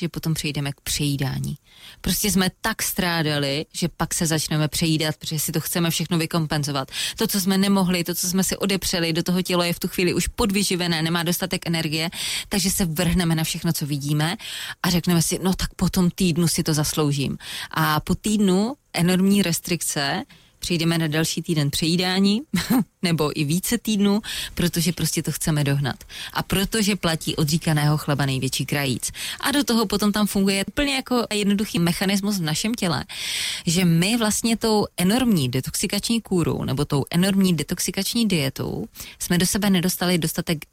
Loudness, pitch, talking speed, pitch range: -22 LUFS, 175 Hz, 170 wpm, 160-195 Hz